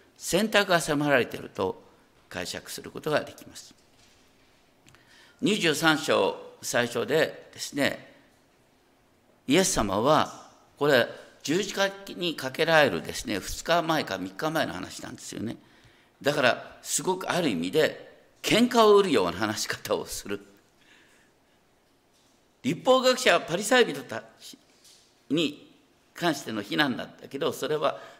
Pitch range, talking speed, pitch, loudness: 150-250 Hz, 250 characters per minute, 180 Hz, -26 LUFS